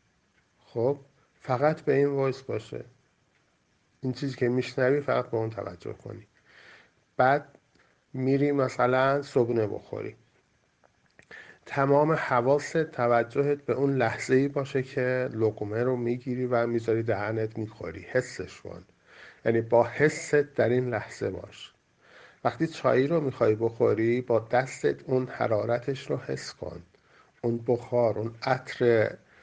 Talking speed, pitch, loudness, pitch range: 125 wpm, 125 Hz, -27 LUFS, 115-140 Hz